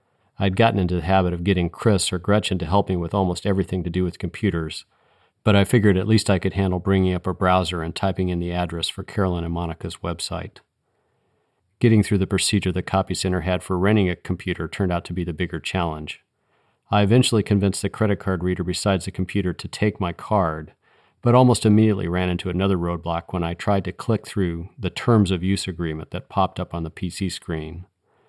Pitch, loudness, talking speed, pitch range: 95 Hz, -22 LUFS, 210 wpm, 90-100 Hz